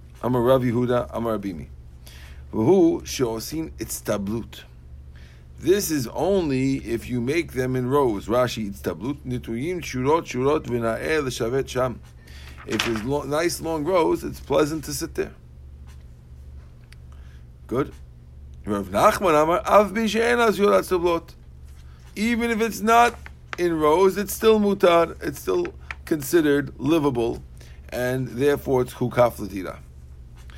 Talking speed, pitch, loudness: 130 wpm, 120 Hz, -22 LUFS